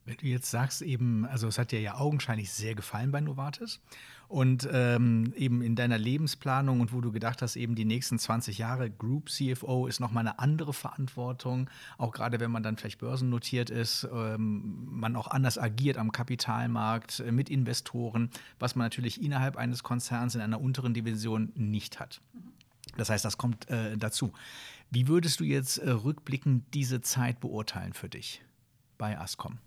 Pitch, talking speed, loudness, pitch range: 120 Hz, 175 wpm, -31 LUFS, 115-130 Hz